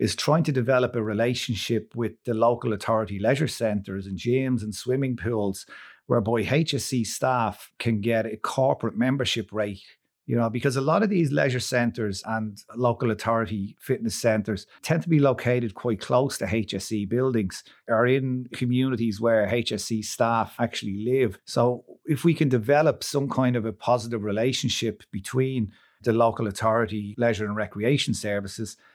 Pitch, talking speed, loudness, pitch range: 115 Hz, 160 wpm, -25 LUFS, 110-130 Hz